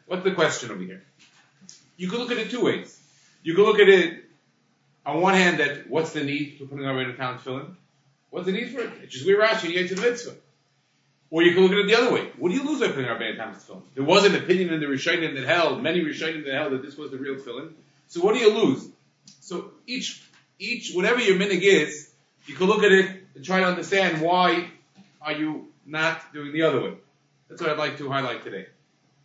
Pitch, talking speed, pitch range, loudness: 170 Hz, 245 wpm, 145-195 Hz, -23 LUFS